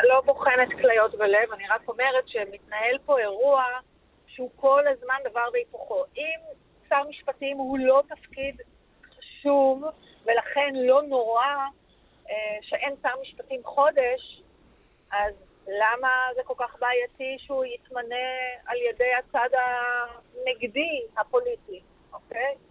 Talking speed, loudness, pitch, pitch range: 115 wpm, -25 LUFS, 260 Hz, 245-280 Hz